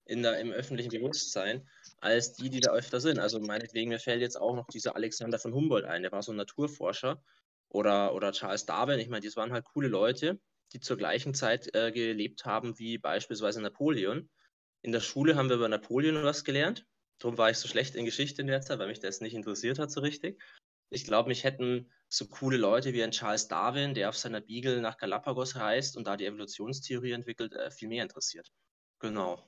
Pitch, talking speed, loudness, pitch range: 120 Hz, 210 wpm, -32 LUFS, 110-135 Hz